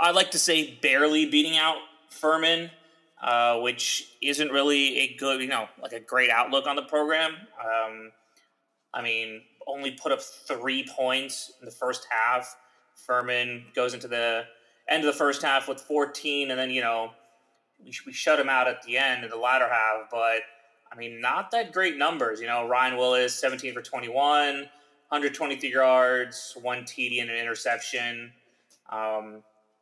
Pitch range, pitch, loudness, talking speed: 120-145 Hz, 130 Hz, -25 LUFS, 170 wpm